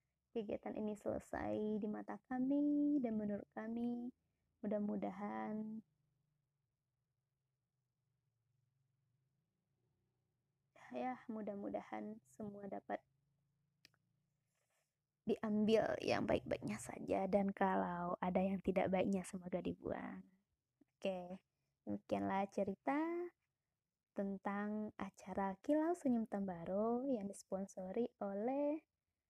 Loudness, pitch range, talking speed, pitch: -42 LUFS, 135-215 Hz, 75 wpm, 190 Hz